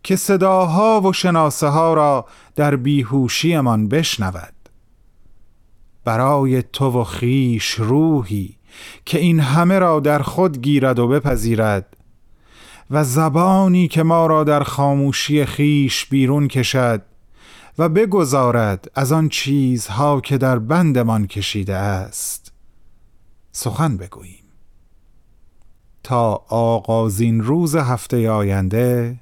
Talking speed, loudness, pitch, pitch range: 105 wpm, -17 LUFS, 130 Hz, 110-150 Hz